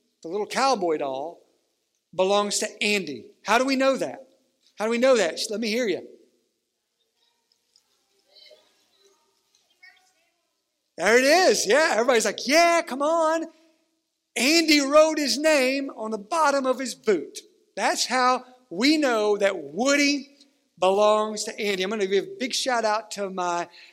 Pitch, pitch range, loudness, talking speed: 265 Hz, 215-320 Hz, -22 LUFS, 150 wpm